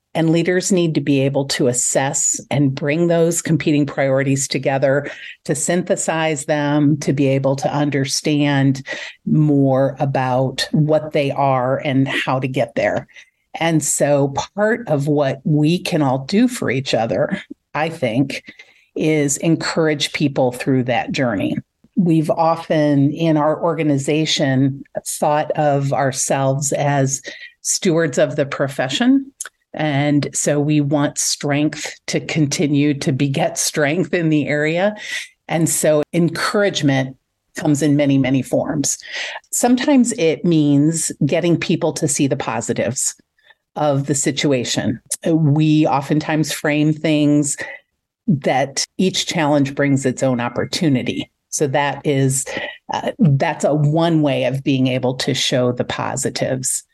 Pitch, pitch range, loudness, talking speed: 150 Hz, 140-160 Hz, -18 LUFS, 130 wpm